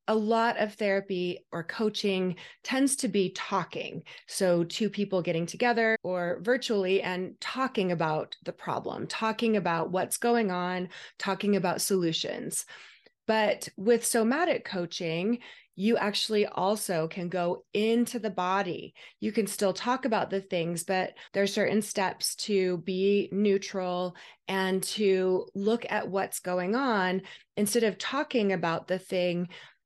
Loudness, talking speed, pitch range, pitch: -29 LUFS, 140 wpm, 180-220 Hz, 195 Hz